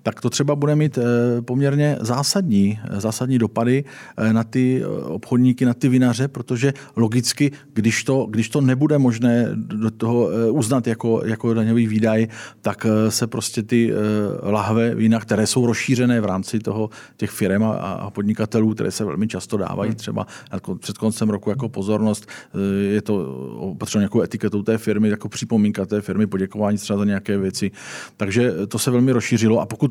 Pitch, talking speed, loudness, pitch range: 115 Hz, 165 wpm, -20 LUFS, 105-125 Hz